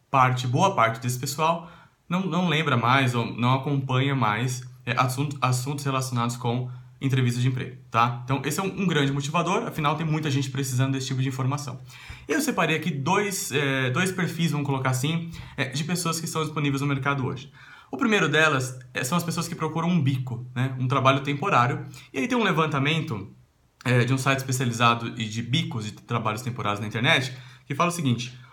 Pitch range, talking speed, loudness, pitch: 125-155 Hz, 190 wpm, -25 LUFS, 135 Hz